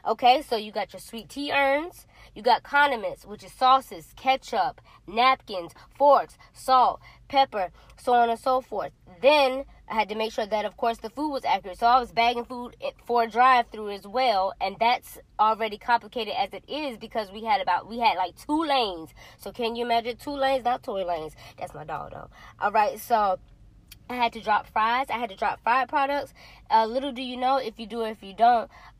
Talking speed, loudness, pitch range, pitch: 215 wpm, -25 LUFS, 210-260 Hz, 235 Hz